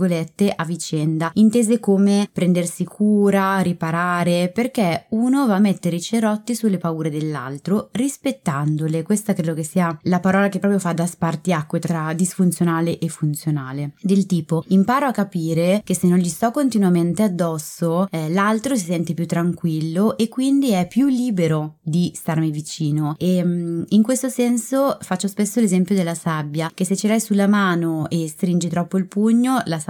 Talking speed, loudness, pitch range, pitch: 165 wpm, -20 LUFS, 165-205 Hz, 180 Hz